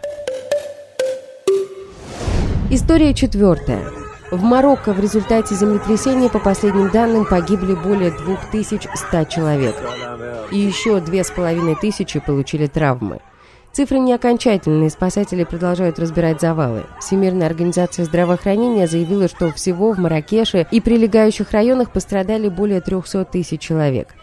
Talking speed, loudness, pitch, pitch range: 105 wpm, -17 LUFS, 195 Hz, 170-225 Hz